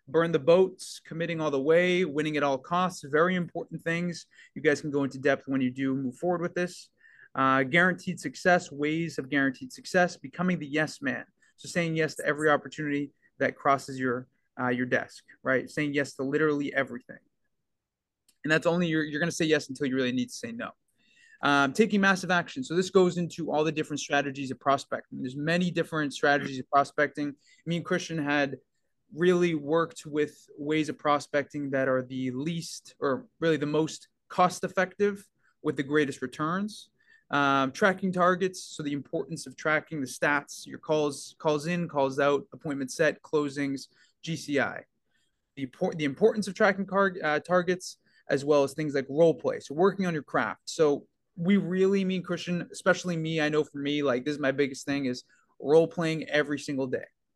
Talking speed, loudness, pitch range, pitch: 185 wpm, -28 LUFS, 140-175 Hz, 155 Hz